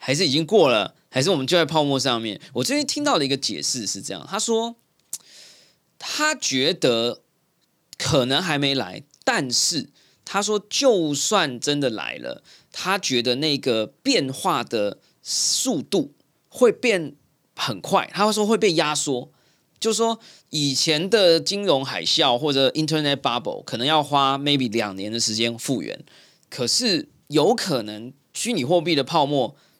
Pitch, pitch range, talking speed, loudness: 150 Hz, 130-195 Hz, 250 characters per minute, -21 LUFS